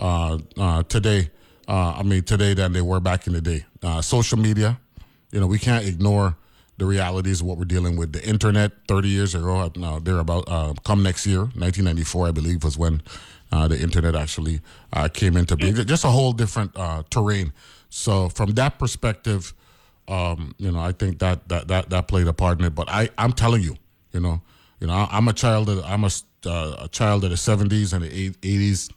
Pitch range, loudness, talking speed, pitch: 85-105 Hz, -22 LUFS, 215 wpm, 95 Hz